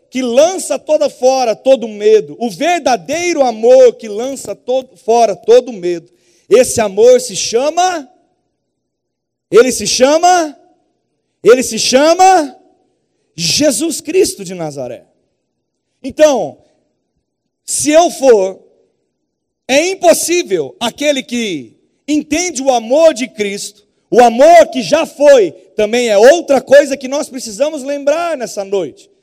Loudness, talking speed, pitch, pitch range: -11 LUFS, 115 wpm, 275 Hz, 235-325 Hz